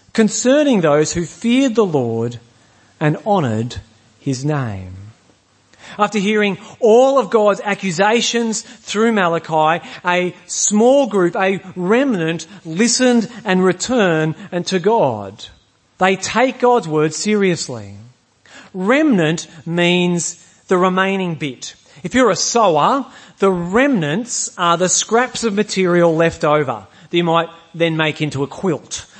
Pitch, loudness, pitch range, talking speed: 180 Hz, -16 LUFS, 155-220 Hz, 120 wpm